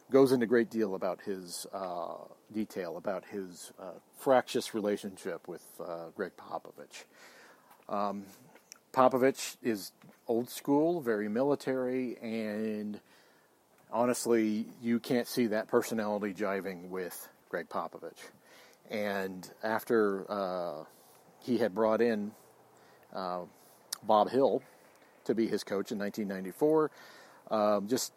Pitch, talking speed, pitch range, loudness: 110 Hz, 115 wpm, 100-120 Hz, -33 LUFS